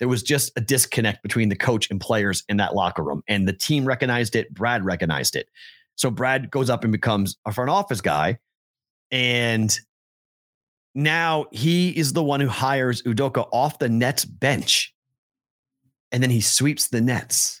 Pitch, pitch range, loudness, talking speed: 125 Hz, 110-140 Hz, -22 LUFS, 175 wpm